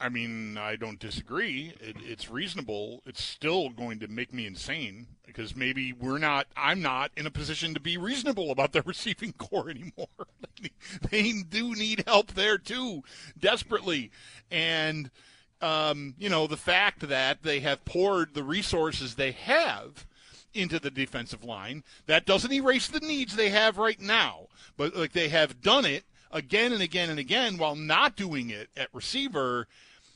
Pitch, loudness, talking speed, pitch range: 155 Hz, -28 LUFS, 165 wpm, 130-205 Hz